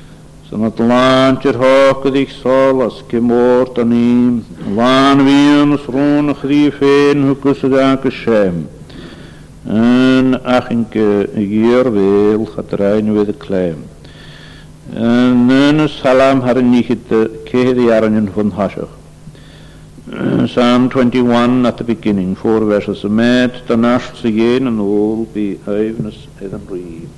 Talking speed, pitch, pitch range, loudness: 130 wpm, 120 Hz, 110-130 Hz, -12 LUFS